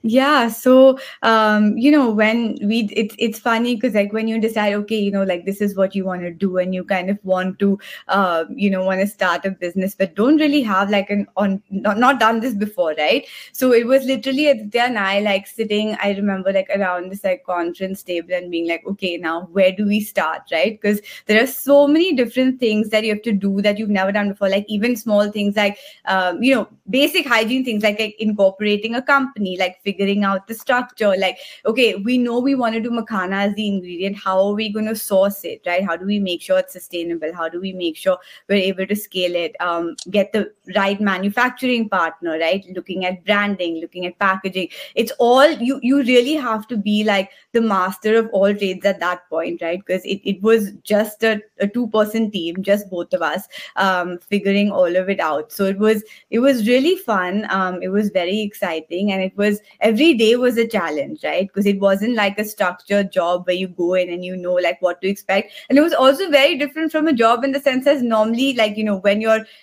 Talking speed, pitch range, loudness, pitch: 230 wpm, 190-230 Hz, -18 LUFS, 205 Hz